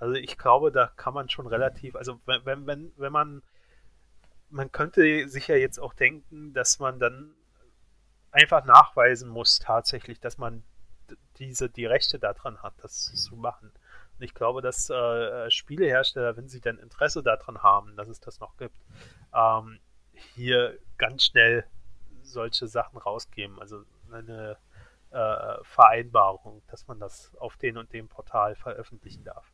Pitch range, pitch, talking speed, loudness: 105-130 Hz, 115 Hz, 150 wpm, -23 LUFS